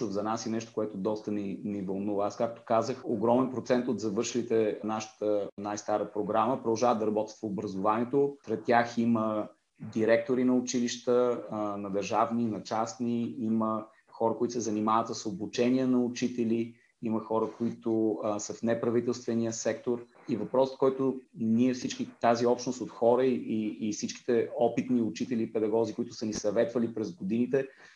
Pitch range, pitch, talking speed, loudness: 110-120 Hz, 115 Hz, 160 wpm, -30 LUFS